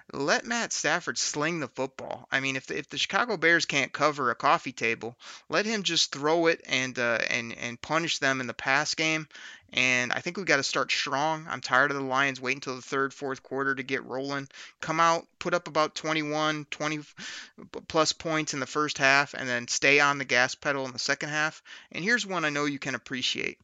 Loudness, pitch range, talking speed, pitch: -27 LUFS, 130-155 Hz, 225 wpm, 140 Hz